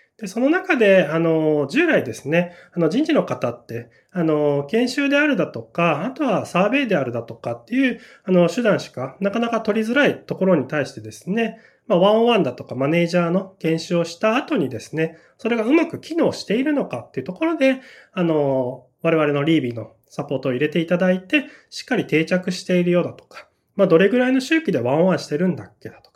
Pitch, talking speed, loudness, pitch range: 180 Hz, 420 characters per minute, -20 LUFS, 150-235 Hz